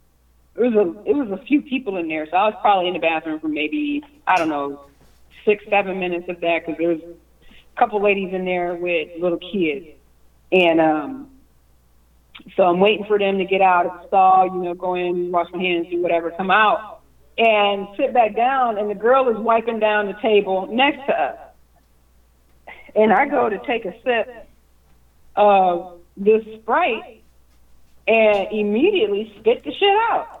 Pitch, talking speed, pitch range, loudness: 185 Hz, 185 wpm, 160-215 Hz, -19 LUFS